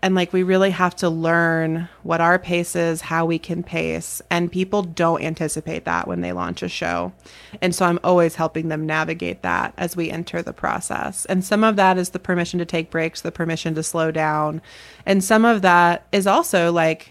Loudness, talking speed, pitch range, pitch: -20 LUFS, 210 wpm, 160-180 Hz, 165 Hz